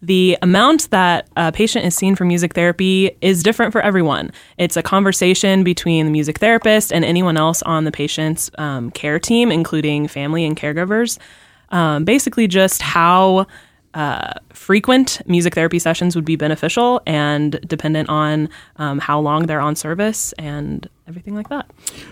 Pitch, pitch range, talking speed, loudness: 175 Hz, 155-195 Hz, 160 wpm, -16 LUFS